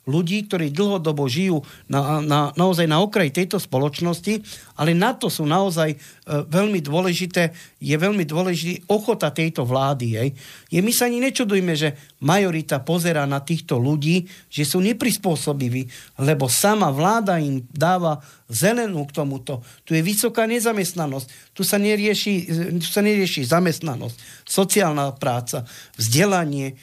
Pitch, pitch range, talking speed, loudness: 165 Hz, 145-190 Hz, 135 wpm, -21 LUFS